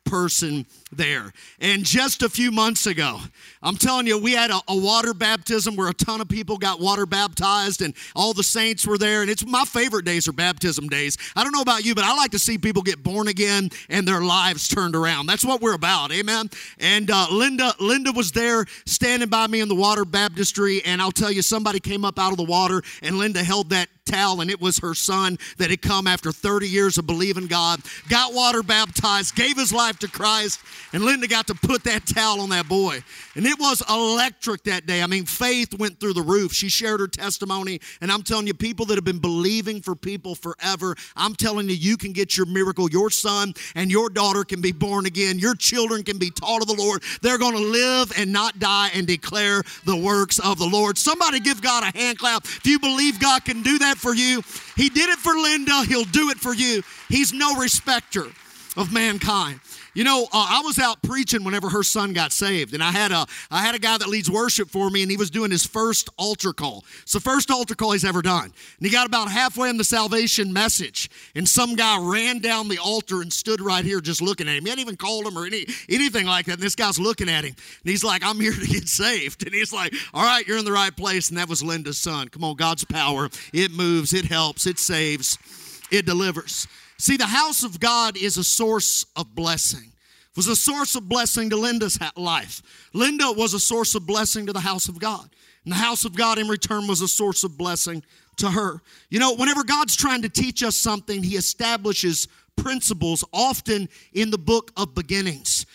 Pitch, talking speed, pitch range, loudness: 205 Hz, 225 wpm, 185-230 Hz, -21 LUFS